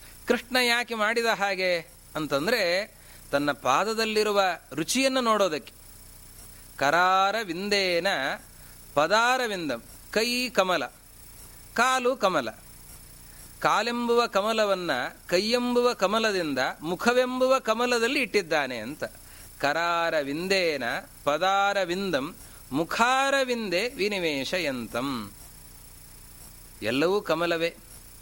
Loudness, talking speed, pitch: -25 LUFS, 70 wpm, 185 Hz